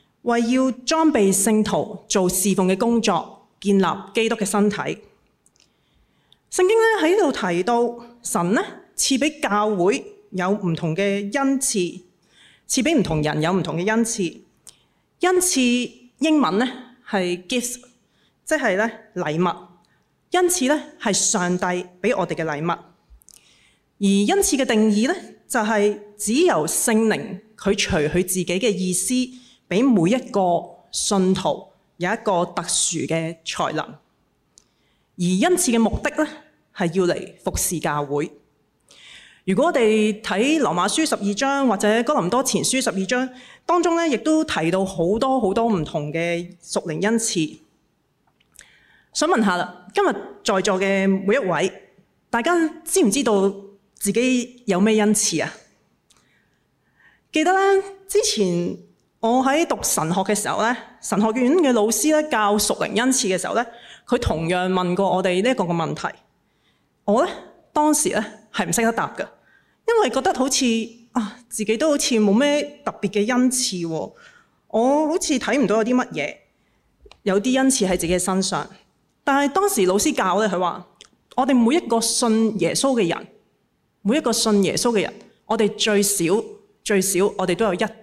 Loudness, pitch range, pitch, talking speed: -21 LUFS, 190-255 Hz, 215 Hz, 220 characters per minute